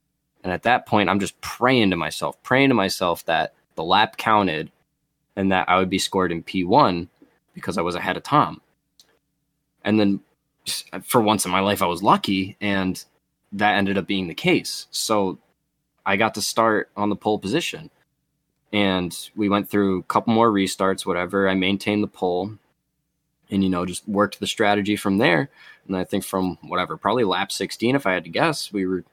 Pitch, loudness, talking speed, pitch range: 95 Hz, -22 LUFS, 190 wpm, 95-105 Hz